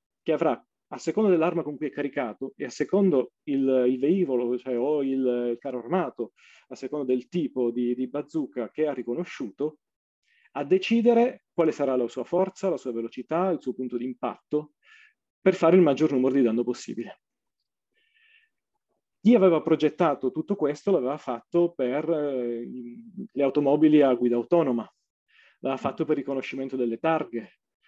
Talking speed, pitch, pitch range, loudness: 160 wpm, 145 Hz, 125-175 Hz, -26 LUFS